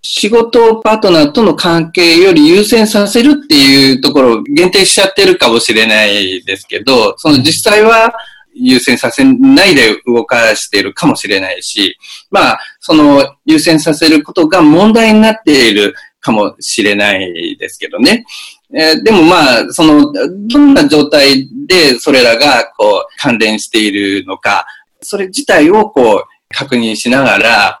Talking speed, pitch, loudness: 300 characters per minute, 230 Hz, -8 LUFS